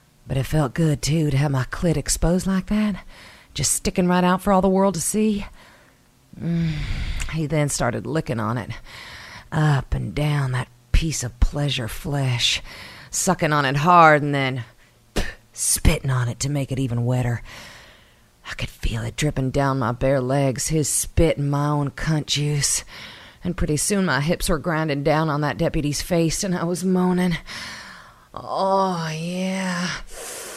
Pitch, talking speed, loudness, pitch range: 150 Hz, 170 wpm, -22 LUFS, 130-175 Hz